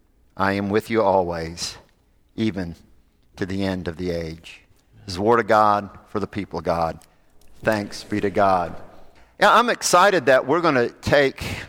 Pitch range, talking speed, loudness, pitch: 85-105 Hz, 180 wpm, -21 LUFS, 95 Hz